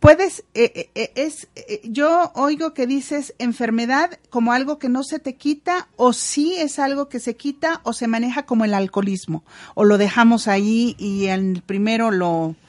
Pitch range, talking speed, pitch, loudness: 205-290 Hz, 180 wpm, 240 Hz, -20 LUFS